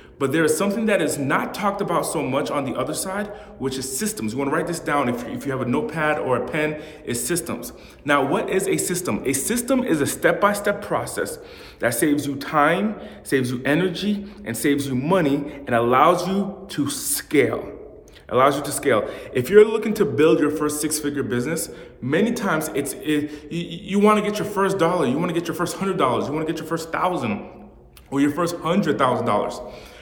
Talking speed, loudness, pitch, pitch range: 215 wpm, -22 LUFS, 165 Hz, 145-200 Hz